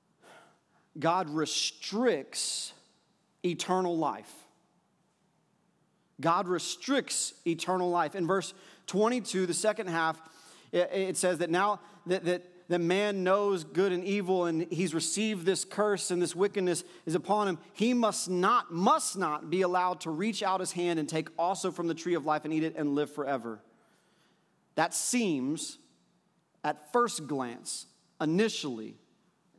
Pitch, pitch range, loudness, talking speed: 180 Hz, 165-200 Hz, -30 LUFS, 140 wpm